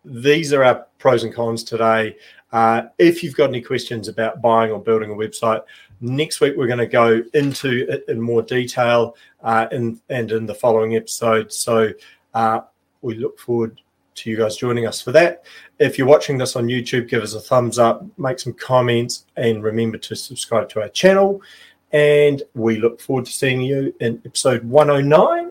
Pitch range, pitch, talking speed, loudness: 115-130 Hz, 120 Hz, 190 wpm, -18 LUFS